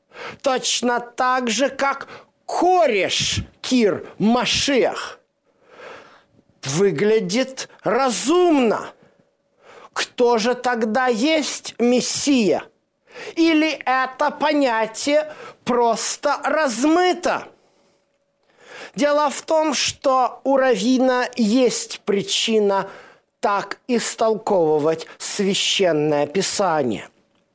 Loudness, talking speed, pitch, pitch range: -19 LUFS, 70 wpm, 255 Hz, 225-290 Hz